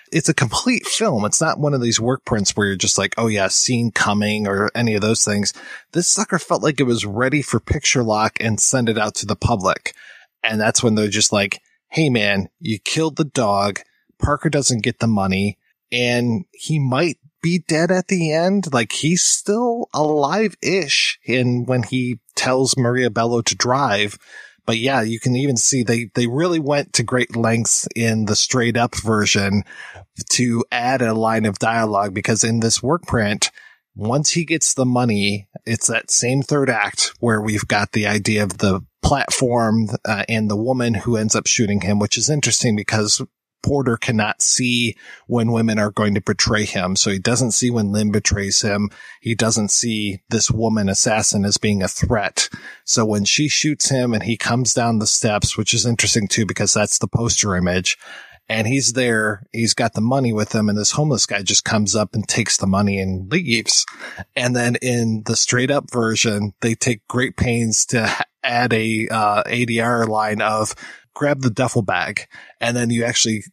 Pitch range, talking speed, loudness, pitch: 105-125 Hz, 190 wpm, -18 LUFS, 115 Hz